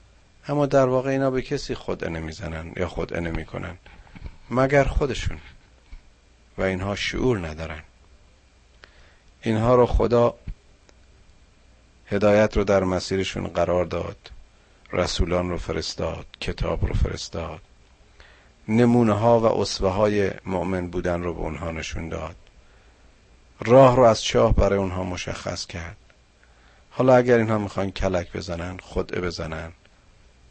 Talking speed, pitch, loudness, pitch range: 120 wpm, 90 Hz, -23 LUFS, 80-105 Hz